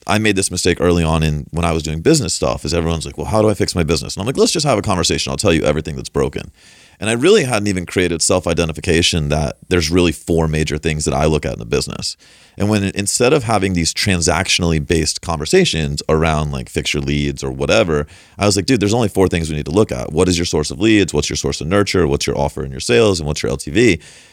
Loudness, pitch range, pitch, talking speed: -16 LUFS, 75-95 Hz, 85 Hz, 265 wpm